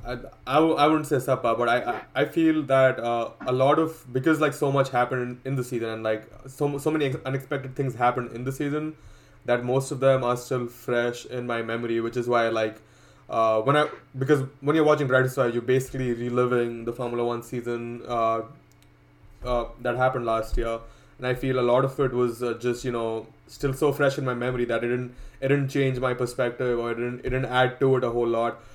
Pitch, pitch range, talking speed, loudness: 125 Hz, 120-135 Hz, 230 wpm, -25 LUFS